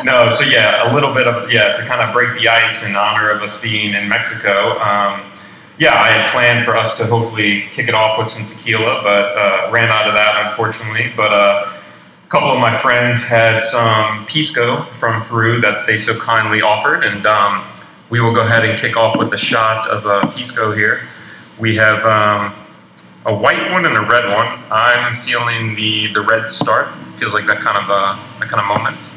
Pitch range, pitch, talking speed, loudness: 105-115 Hz, 110 Hz, 210 wpm, -13 LUFS